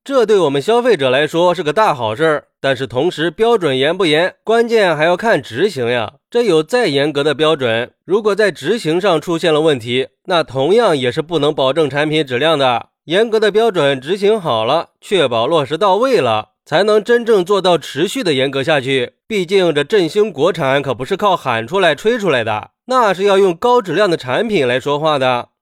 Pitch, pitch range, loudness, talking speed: 165 Hz, 140-215 Hz, -15 LUFS, 295 characters per minute